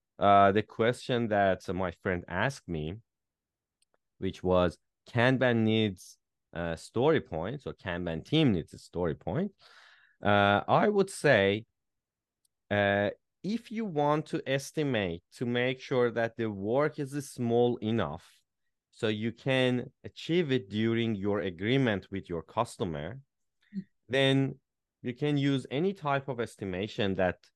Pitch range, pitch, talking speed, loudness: 95-135 Hz, 115 Hz, 135 wpm, -30 LUFS